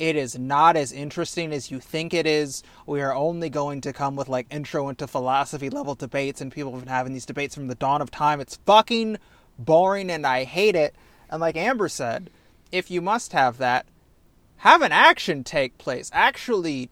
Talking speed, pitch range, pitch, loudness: 200 wpm, 140-165 Hz, 145 Hz, -23 LUFS